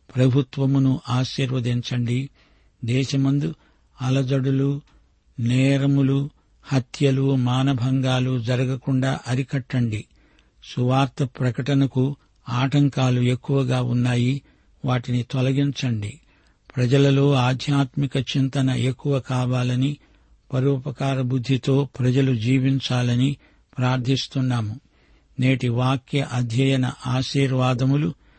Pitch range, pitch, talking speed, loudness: 125-135 Hz, 130 Hz, 65 wpm, -22 LUFS